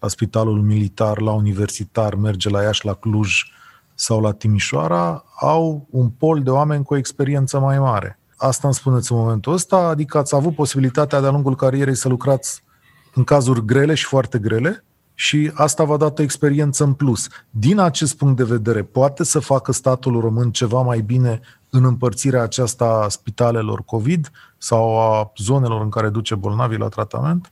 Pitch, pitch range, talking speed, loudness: 125 Hz, 110-140 Hz, 175 wpm, -18 LUFS